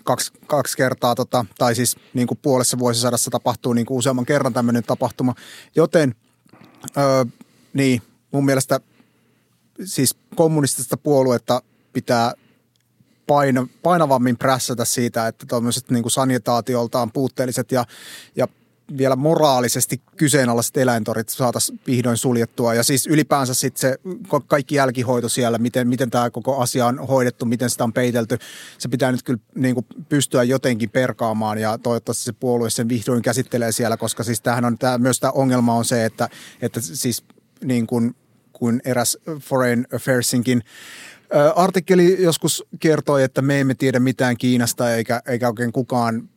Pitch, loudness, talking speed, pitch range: 125 Hz, -19 LUFS, 145 wpm, 120-135 Hz